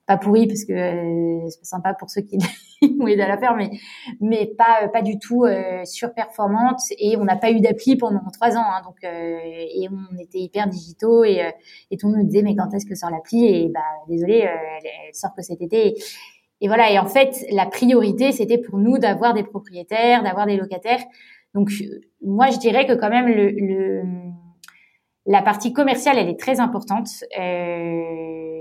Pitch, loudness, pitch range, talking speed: 205 Hz, -19 LUFS, 185-230 Hz, 205 wpm